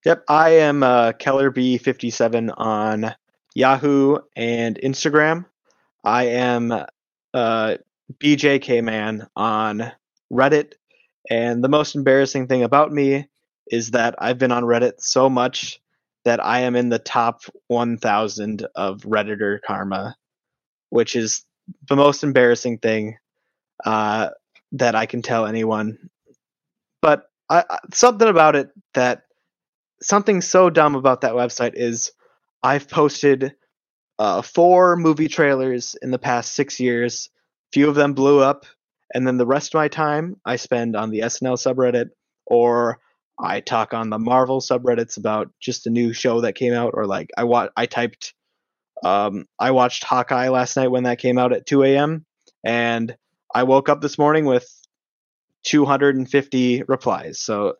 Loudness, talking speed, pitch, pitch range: -19 LUFS, 145 wpm, 125 Hz, 115-140 Hz